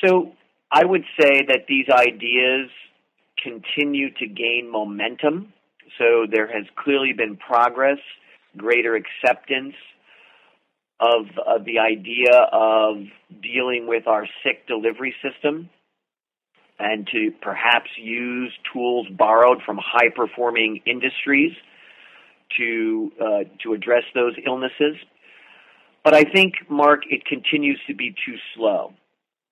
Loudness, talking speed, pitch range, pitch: -19 LUFS, 115 wpm, 115-145 Hz, 125 Hz